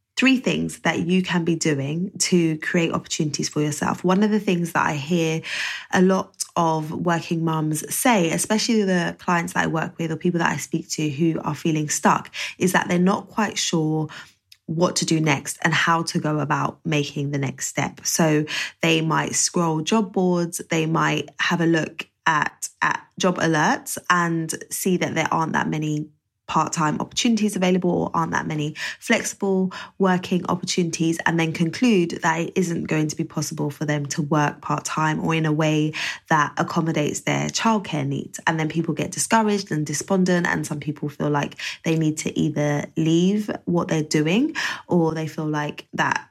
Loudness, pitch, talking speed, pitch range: -22 LUFS, 165 Hz, 185 wpm, 155-180 Hz